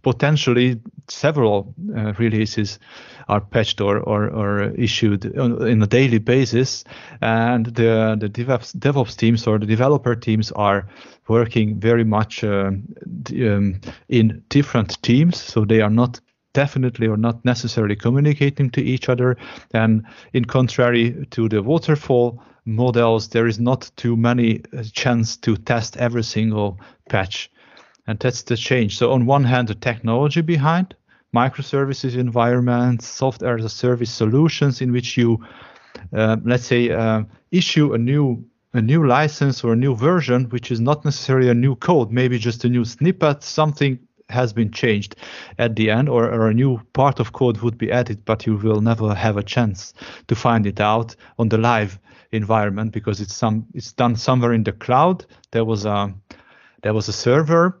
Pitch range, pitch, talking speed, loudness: 110-130 Hz, 120 Hz, 165 wpm, -19 LUFS